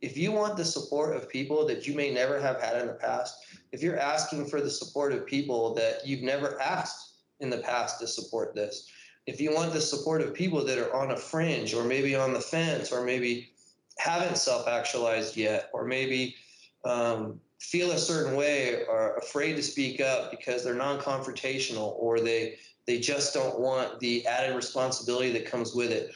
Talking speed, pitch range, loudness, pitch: 195 wpm, 120-155 Hz, -30 LUFS, 135 Hz